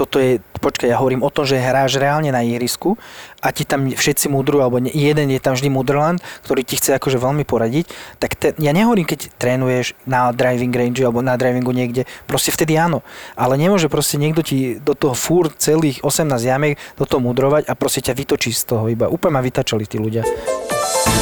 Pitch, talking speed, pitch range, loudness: 135 Hz, 200 wpm, 125-150 Hz, -17 LUFS